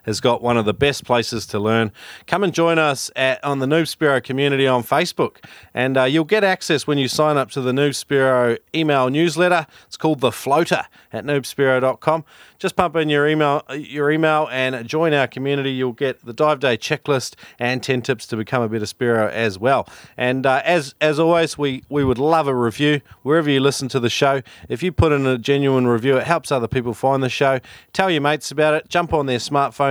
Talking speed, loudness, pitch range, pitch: 220 wpm, -19 LUFS, 125-155 Hz, 140 Hz